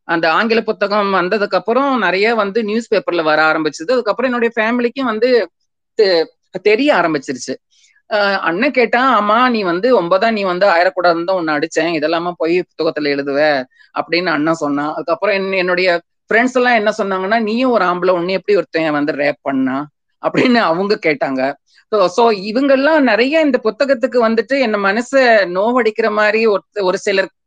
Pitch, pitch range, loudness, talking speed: 205 Hz, 170-240 Hz, -15 LUFS, 140 wpm